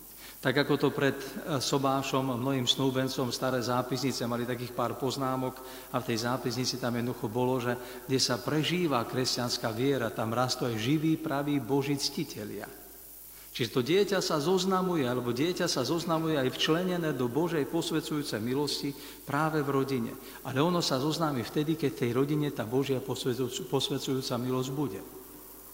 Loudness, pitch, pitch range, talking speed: -30 LUFS, 135 Hz, 125-150 Hz, 150 wpm